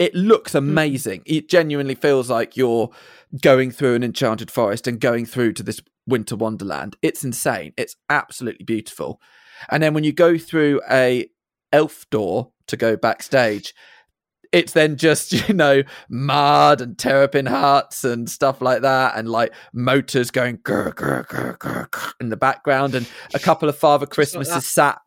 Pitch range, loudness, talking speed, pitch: 120-150 Hz, -19 LUFS, 155 wpm, 135 Hz